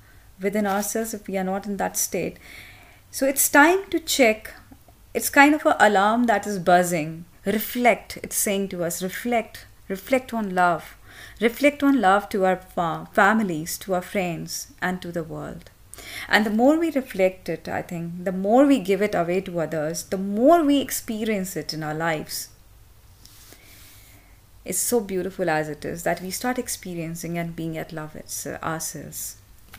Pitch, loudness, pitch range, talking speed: 185 Hz, -23 LUFS, 155-220 Hz, 175 wpm